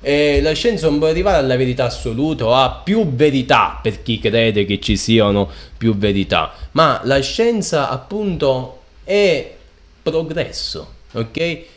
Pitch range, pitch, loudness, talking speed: 115-160 Hz, 135 Hz, -17 LUFS, 145 wpm